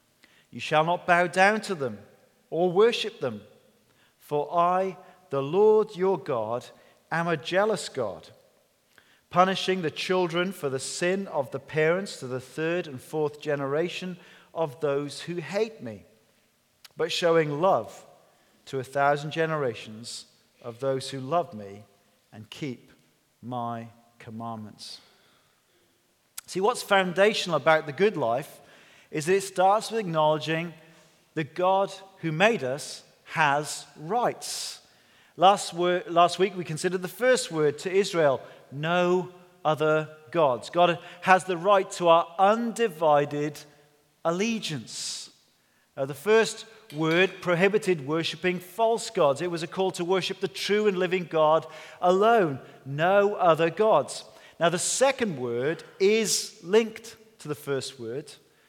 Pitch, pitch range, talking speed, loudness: 170 Hz, 145-190 Hz, 135 wpm, -26 LUFS